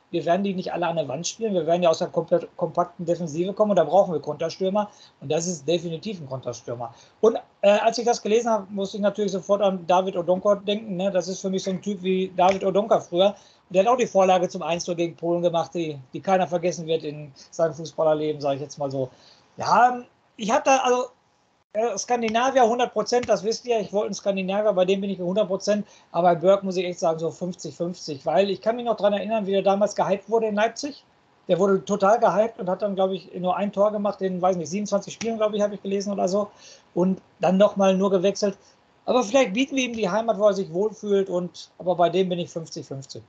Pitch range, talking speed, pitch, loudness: 175-210 Hz, 240 wpm, 190 Hz, -23 LUFS